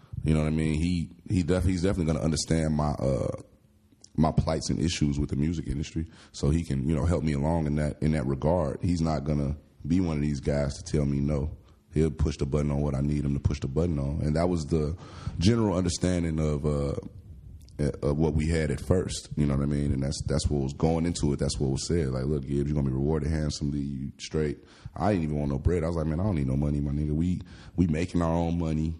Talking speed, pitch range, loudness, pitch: 255 wpm, 70-85 Hz, -28 LUFS, 75 Hz